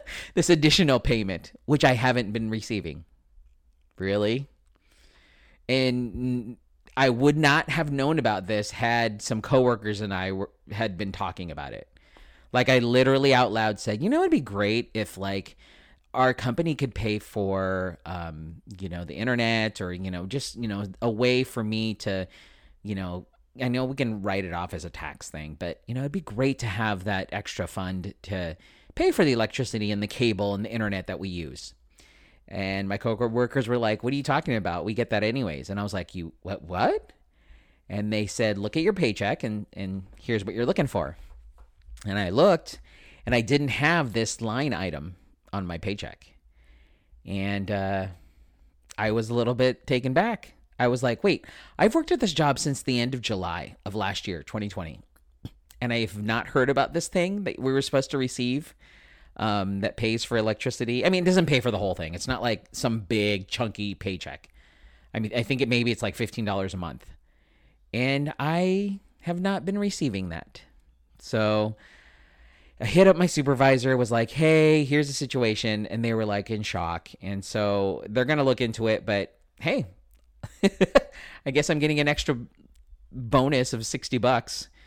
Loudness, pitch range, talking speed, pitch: -26 LUFS, 95-130 Hz, 185 wpm, 110 Hz